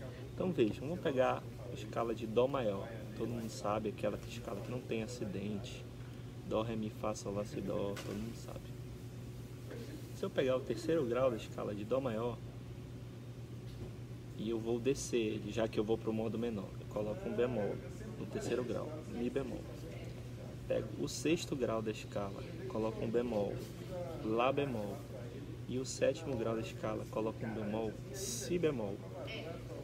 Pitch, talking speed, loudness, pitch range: 120 Hz, 165 wpm, -39 LUFS, 110-125 Hz